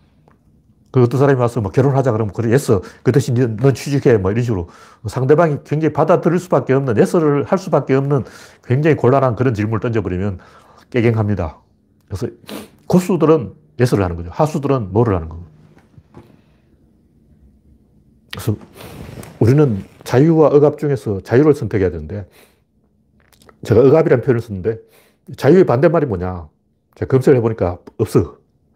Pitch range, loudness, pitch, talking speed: 100-145 Hz, -16 LUFS, 125 Hz, 335 characters per minute